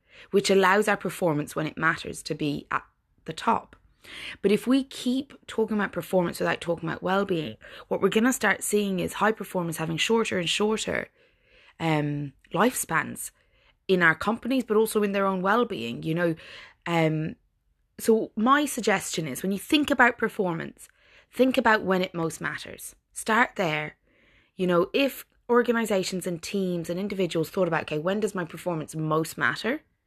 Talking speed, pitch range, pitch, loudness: 170 wpm, 170-220 Hz, 190 Hz, -26 LUFS